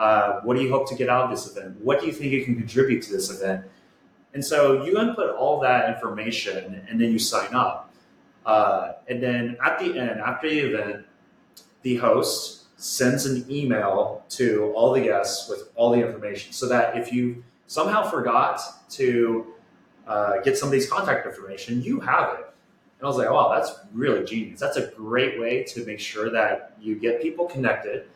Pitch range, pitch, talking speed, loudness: 115-135 Hz, 120 Hz, 195 wpm, -24 LUFS